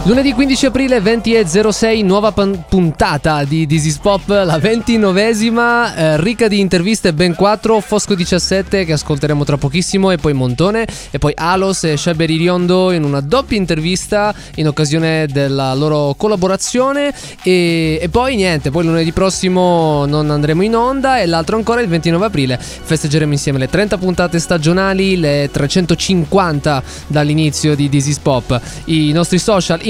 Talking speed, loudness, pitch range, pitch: 145 wpm, -13 LUFS, 155-205 Hz, 180 Hz